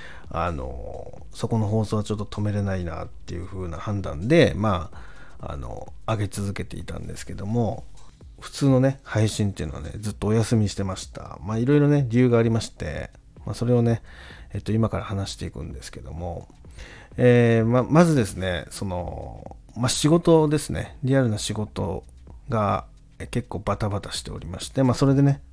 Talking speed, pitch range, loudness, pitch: 355 characters per minute, 95-120 Hz, -24 LUFS, 105 Hz